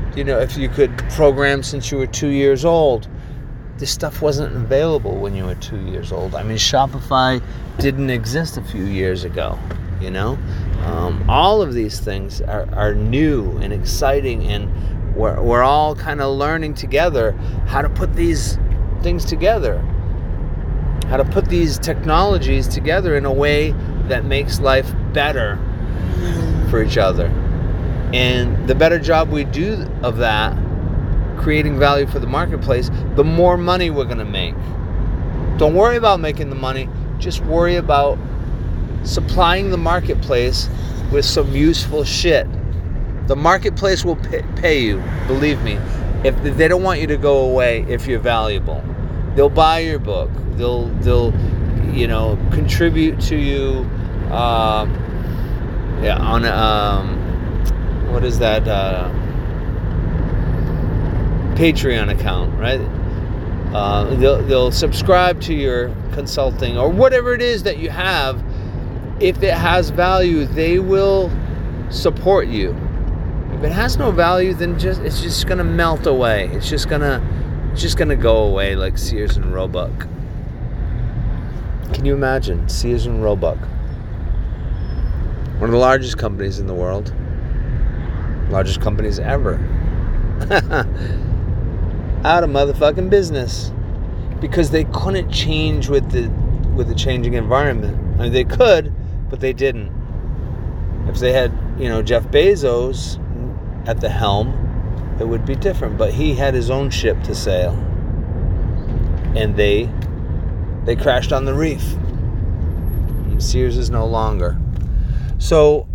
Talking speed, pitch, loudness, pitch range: 140 wpm, 110 Hz, -18 LUFS, 90-135 Hz